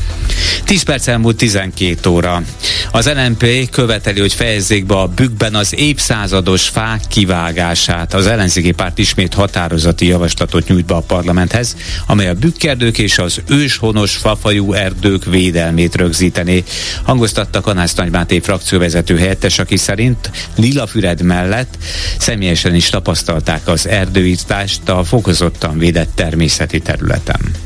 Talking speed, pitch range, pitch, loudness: 120 wpm, 85-110 Hz, 95 Hz, -13 LUFS